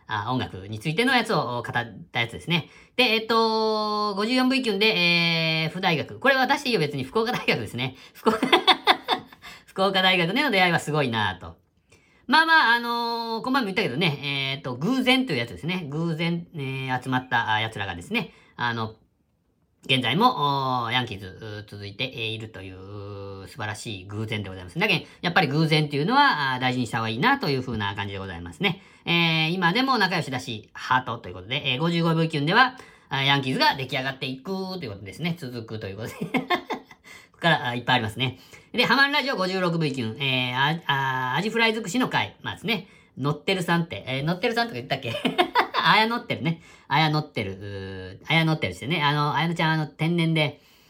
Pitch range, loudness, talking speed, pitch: 115-190 Hz, -23 LUFS, 400 characters per minute, 145 Hz